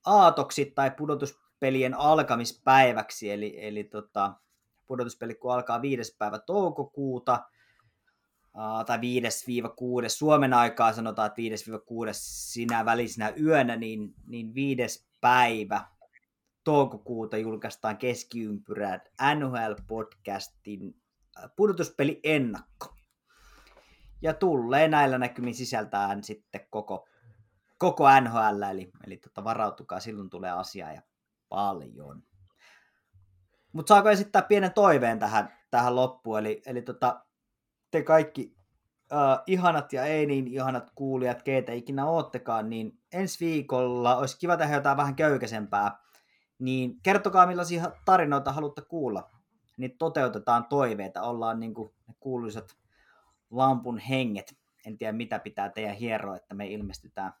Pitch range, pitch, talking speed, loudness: 110-140 Hz, 125 Hz, 115 wpm, -27 LUFS